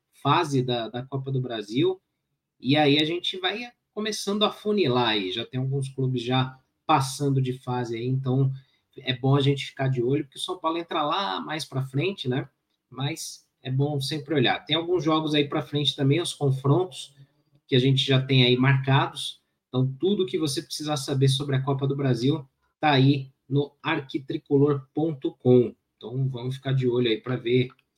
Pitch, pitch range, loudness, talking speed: 140 Hz, 130-155 Hz, -25 LUFS, 185 wpm